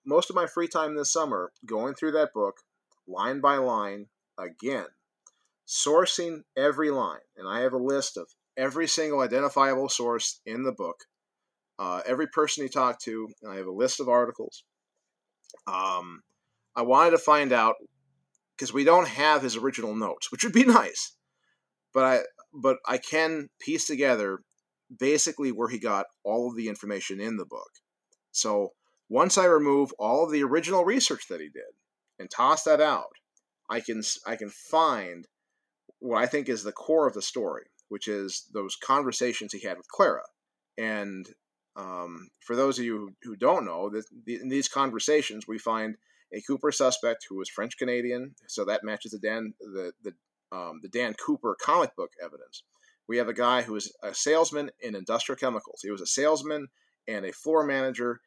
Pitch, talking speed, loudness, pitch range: 135 Hz, 175 wpm, -27 LUFS, 115-155 Hz